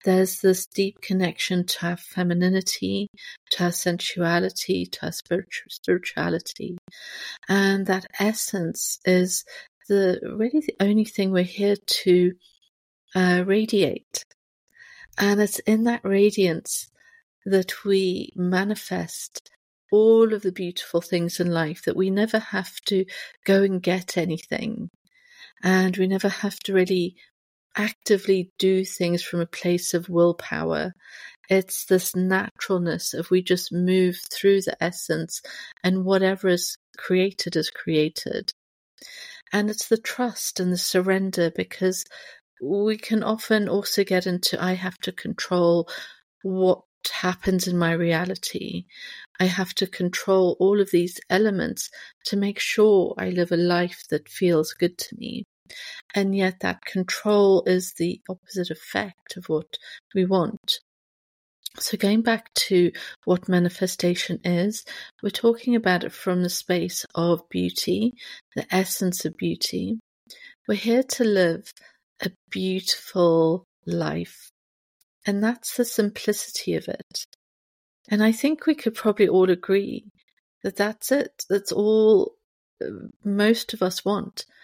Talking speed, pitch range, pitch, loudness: 135 wpm, 180-210 Hz, 190 Hz, -23 LUFS